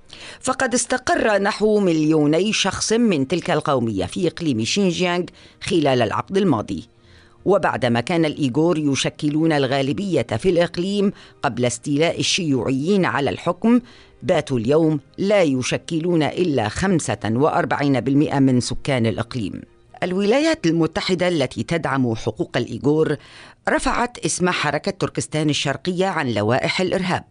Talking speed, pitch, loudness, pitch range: 110 wpm, 155 Hz, -20 LUFS, 135-180 Hz